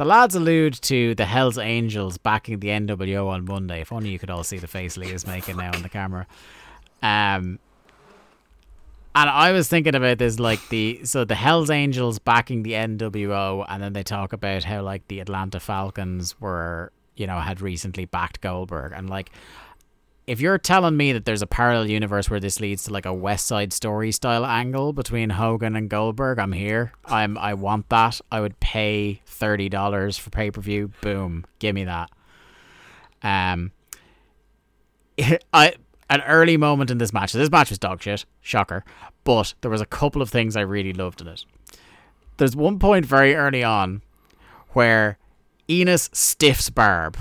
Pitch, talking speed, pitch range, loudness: 105 Hz, 180 wpm, 95-120 Hz, -21 LUFS